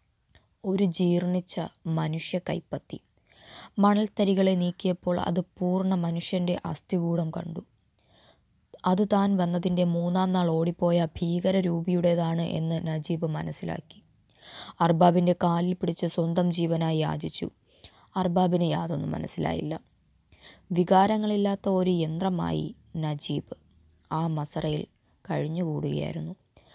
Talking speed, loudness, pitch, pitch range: 85 wpm, -27 LUFS, 175 Hz, 165-185 Hz